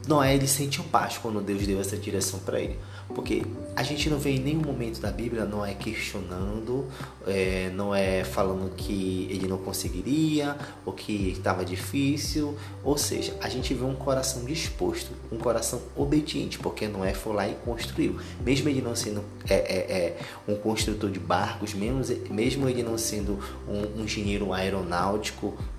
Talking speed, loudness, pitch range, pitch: 170 wpm, -28 LUFS, 95-130 Hz, 105 Hz